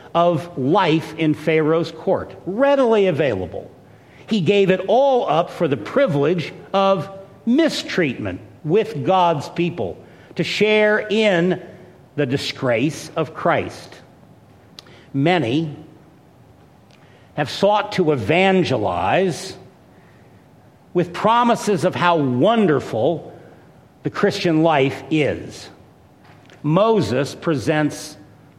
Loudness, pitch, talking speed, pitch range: -19 LUFS, 170 Hz, 90 wpm, 150-195 Hz